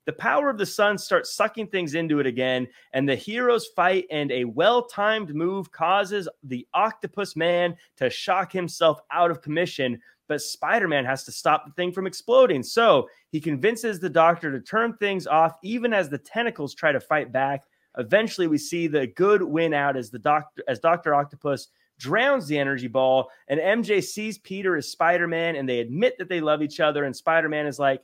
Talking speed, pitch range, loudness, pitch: 195 wpm, 145-200 Hz, -24 LUFS, 165 Hz